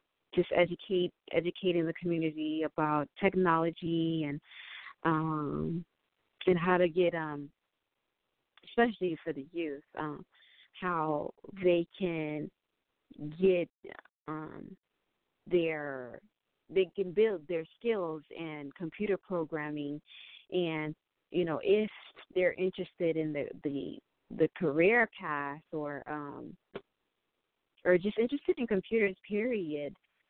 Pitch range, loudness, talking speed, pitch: 155-185 Hz, -33 LUFS, 105 wpm, 165 Hz